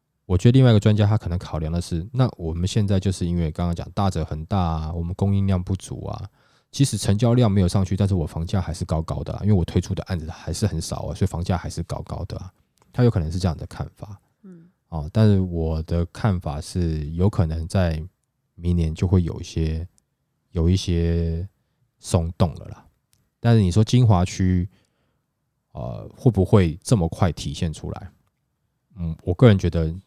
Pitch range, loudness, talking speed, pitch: 85-105 Hz, -22 LUFS, 290 characters per minute, 95 Hz